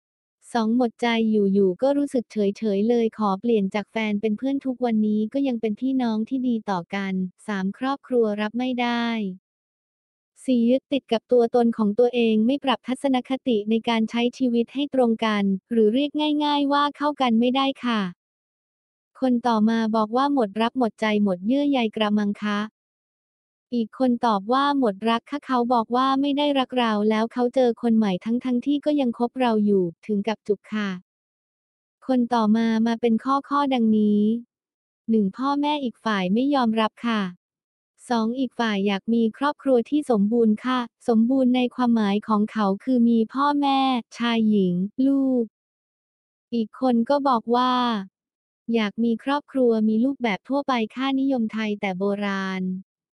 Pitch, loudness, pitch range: 235 Hz, -23 LUFS, 215-255 Hz